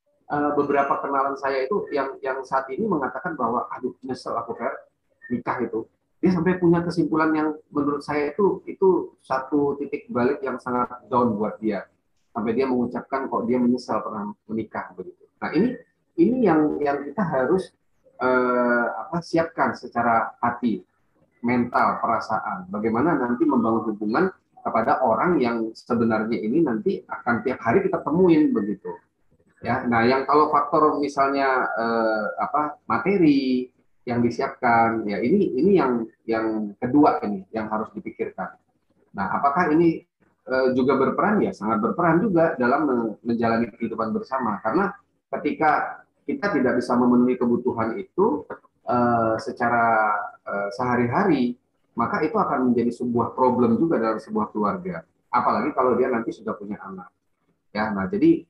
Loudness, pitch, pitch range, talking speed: -23 LUFS, 125 Hz, 115-145 Hz, 145 wpm